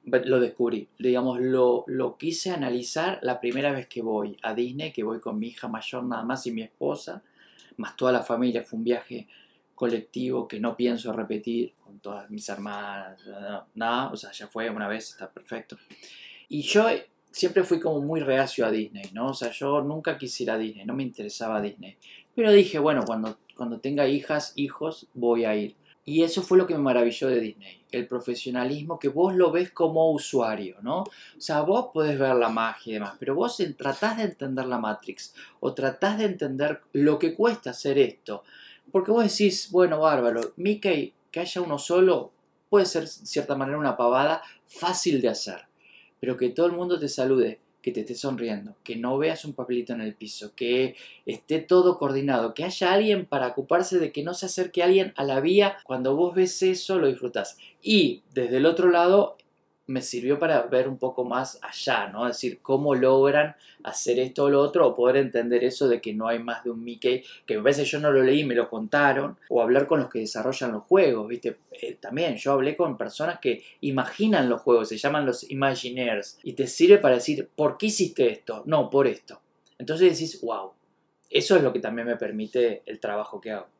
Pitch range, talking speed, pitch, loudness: 120-170 Hz, 205 wpm, 135 Hz, -25 LUFS